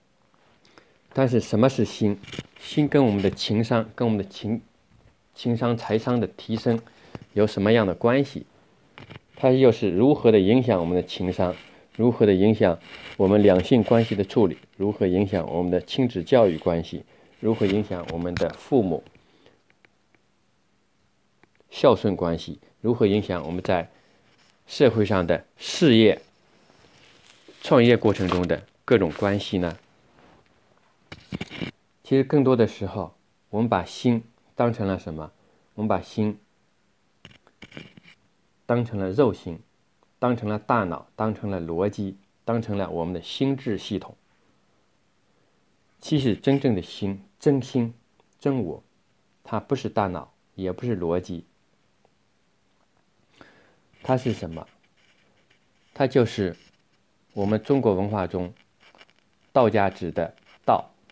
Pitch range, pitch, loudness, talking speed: 90-115 Hz, 105 Hz, -23 LUFS, 190 characters per minute